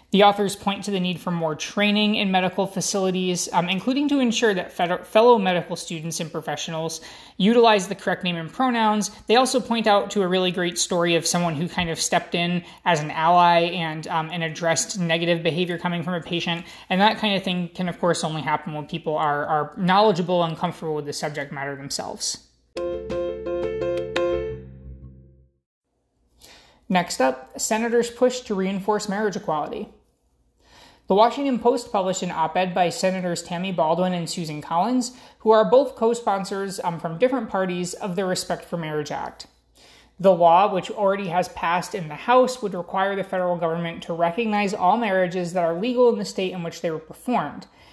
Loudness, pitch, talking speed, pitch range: -22 LUFS, 180 Hz, 185 wpm, 165-205 Hz